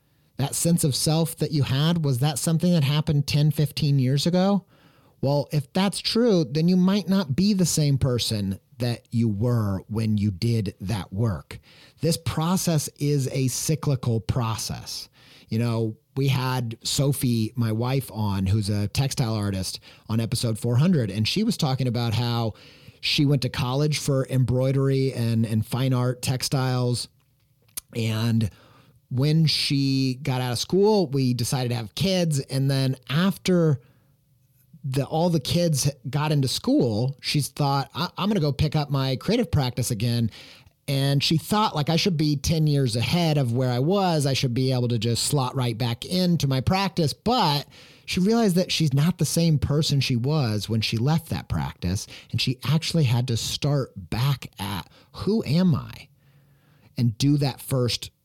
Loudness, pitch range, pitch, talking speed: -24 LUFS, 120-150 Hz, 135 Hz, 170 wpm